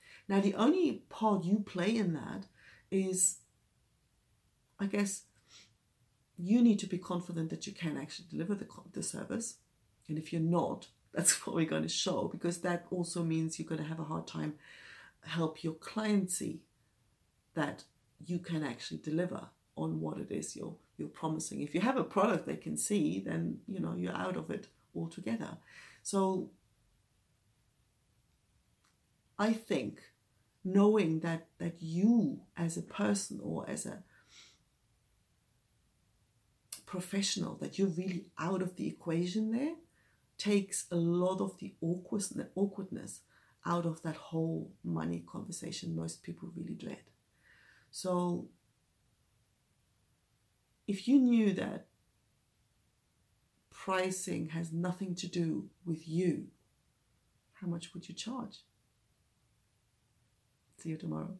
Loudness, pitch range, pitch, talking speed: -35 LUFS, 115-190 Hz, 165 Hz, 130 wpm